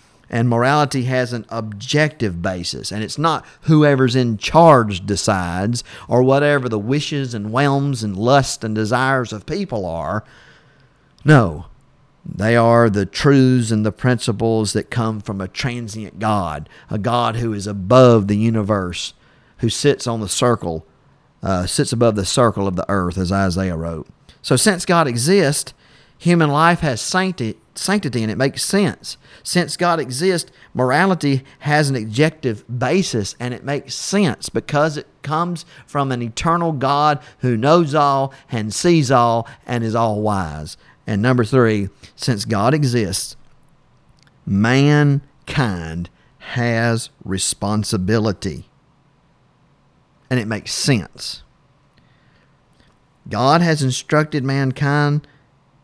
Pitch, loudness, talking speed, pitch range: 125 Hz, -18 LUFS, 130 wpm, 110-145 Hz